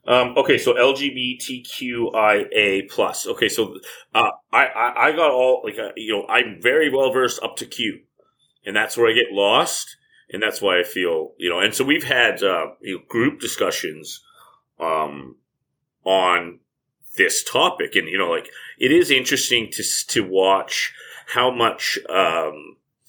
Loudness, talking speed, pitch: -19 LUFS, 165 wpm, 145 Hz